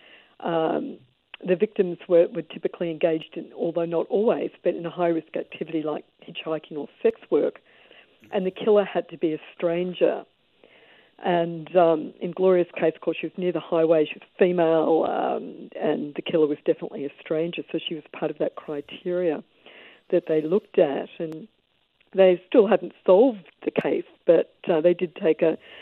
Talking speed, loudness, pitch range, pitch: 175 wpm, -24 LUFS, 160-185 Hz, 170 Hz